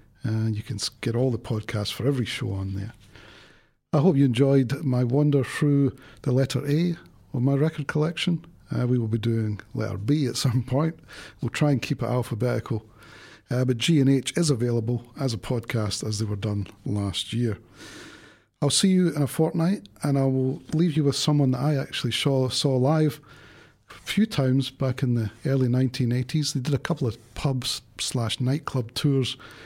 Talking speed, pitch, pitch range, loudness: 190 wpm, 130 Hz, 115-145 Hz, -25 LUFS